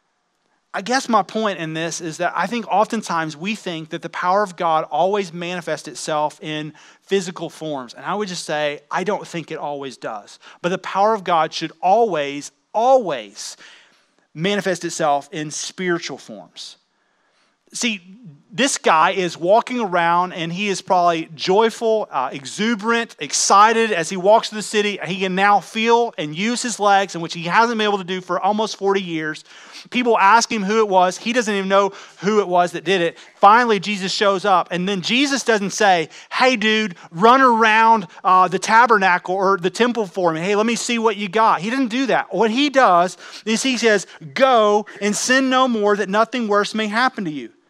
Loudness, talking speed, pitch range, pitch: -18 LUFS, 195 wpm, 170-225 Hz, 195 Hz